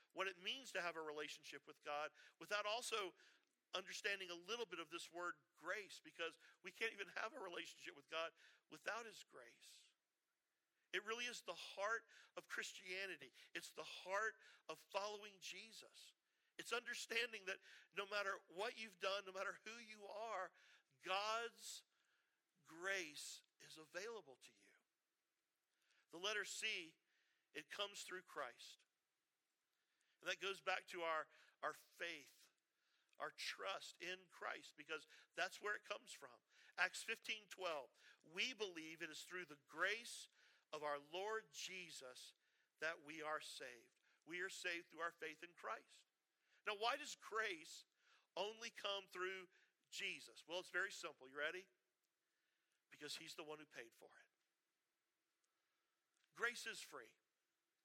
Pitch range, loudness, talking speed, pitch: 165-215 Hz, -49 LUFS, 145 wpm, 190 Hz